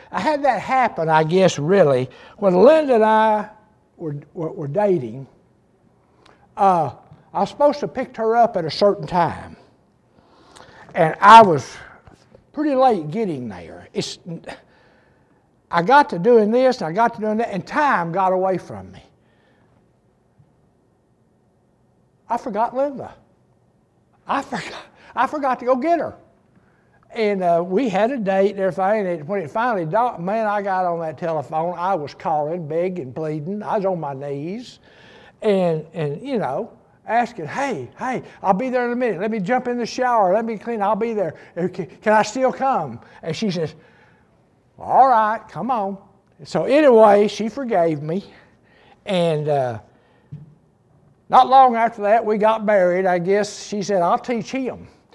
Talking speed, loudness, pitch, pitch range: 165 wpm, -19 LUFS, 200 Hz, 170-230 Hz